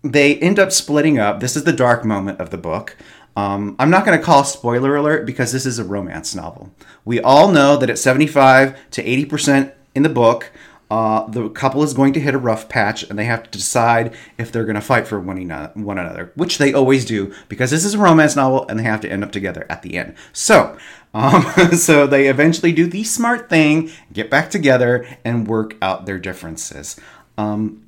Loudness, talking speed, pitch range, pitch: -15 LUFS, 215 wpm, 110-150 Hz, 130 Hz